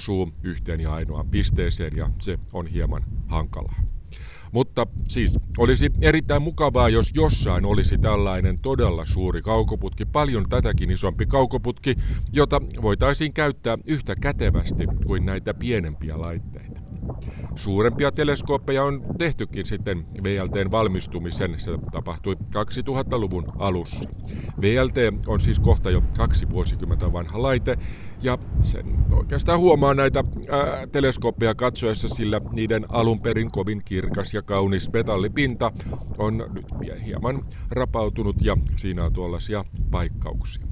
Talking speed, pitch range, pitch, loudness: 120 wpm, 90-115 Hz, 105 Hz, -24 LUFS